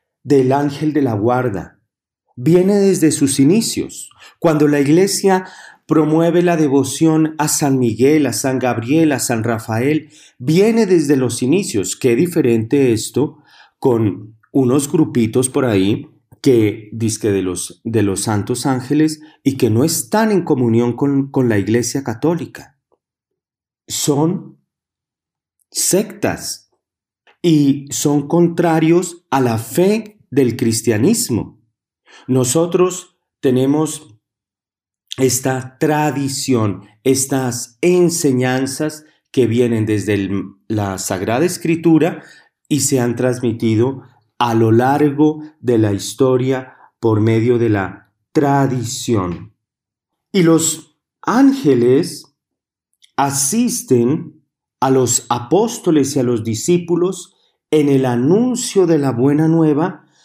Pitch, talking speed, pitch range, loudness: 135 Hz, 110 wpm, 120-155 Hz, -16 LUFS